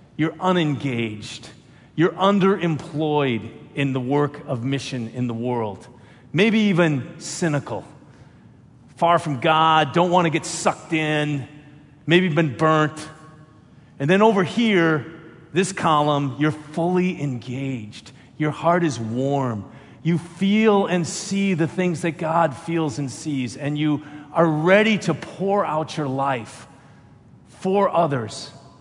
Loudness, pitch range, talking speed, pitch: -21 LUFS, 135-170 Hz, 130 wpm, 155 Hz